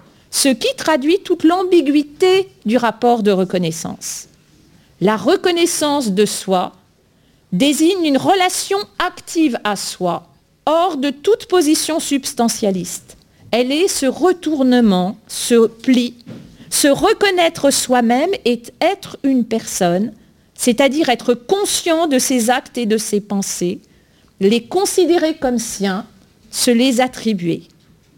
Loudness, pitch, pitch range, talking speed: -16 LUFS, 260 Hz, 220-330 Hz, 115 wpm